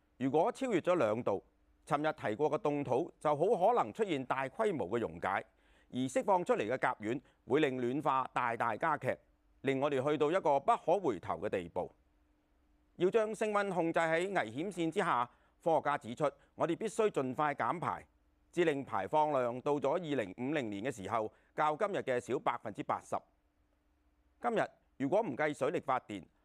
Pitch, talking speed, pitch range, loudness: 145 Hz, 265 characters per minute, 105-165 Hz, -34 LUFS